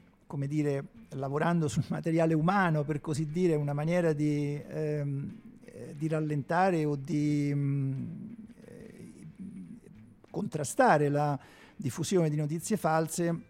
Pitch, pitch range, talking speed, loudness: 160 Hz, 145-185 Hz, 105 wpm, -30 LUFS